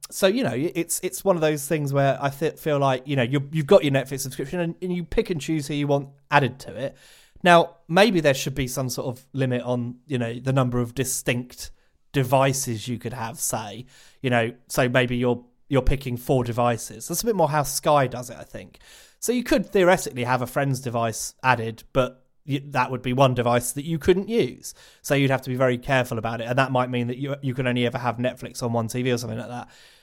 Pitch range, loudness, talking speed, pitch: 125-150 Hz, -23 LUFS, 245 wpm, 130 Hz